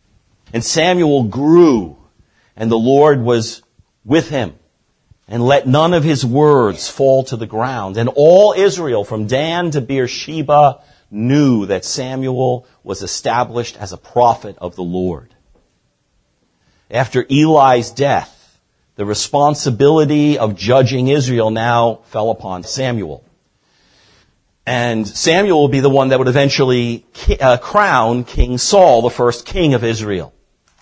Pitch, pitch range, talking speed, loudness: 125 Hz, 110-140 Hz, 130 wpm, -14 LUFS